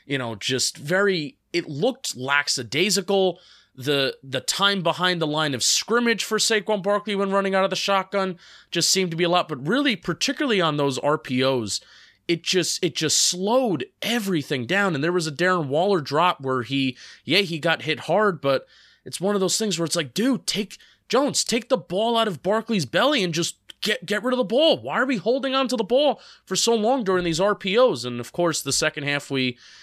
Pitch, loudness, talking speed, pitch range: 185 Hz, -22 LUFS, 210 wpm, 155-215 Hz